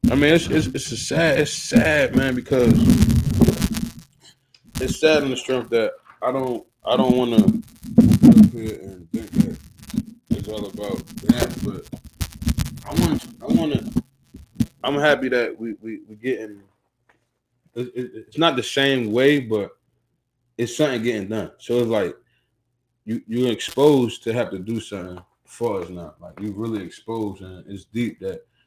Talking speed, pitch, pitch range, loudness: 155 wpm, 120 Hz, 110-140 Hz, -20 LUFS